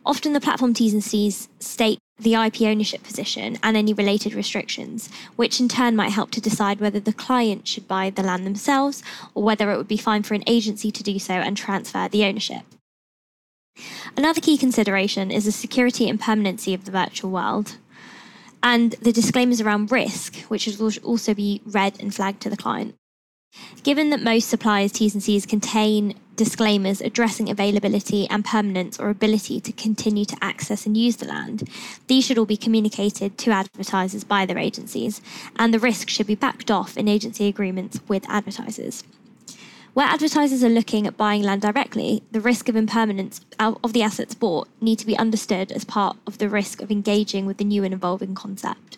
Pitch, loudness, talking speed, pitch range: 215 Hz, -22 LUFS, 185 wpm, 205-230 Hz